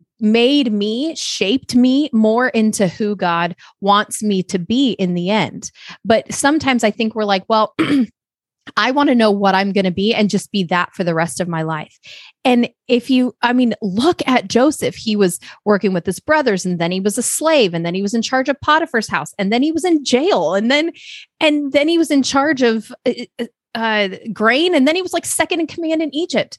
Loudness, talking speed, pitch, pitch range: -16 LUFS, 220 wpm, 230 Hz, 200-280 Hz